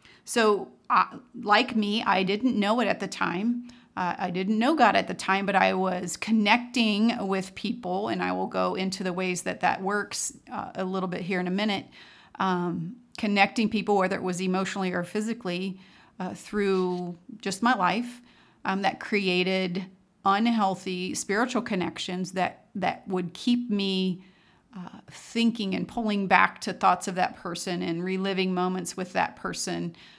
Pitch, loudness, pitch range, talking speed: 190 Hz, -27 LUFS, 185-215 Hz, 165 wpm